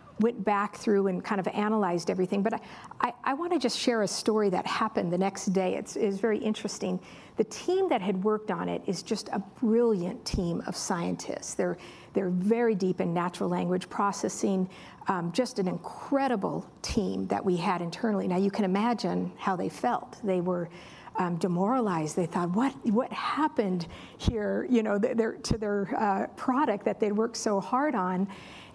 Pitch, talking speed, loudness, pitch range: 205 Hz, 185 wpm, -29 LUFS, 185-230 Hz